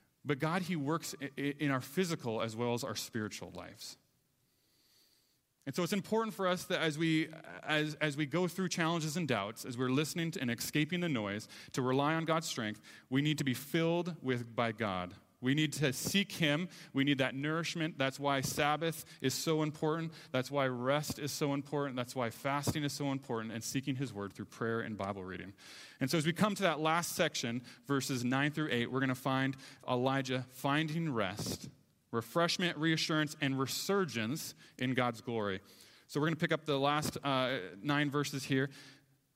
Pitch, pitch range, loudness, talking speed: 140 Hz, 125-155 Hz, -35 LUFS, 190 wpm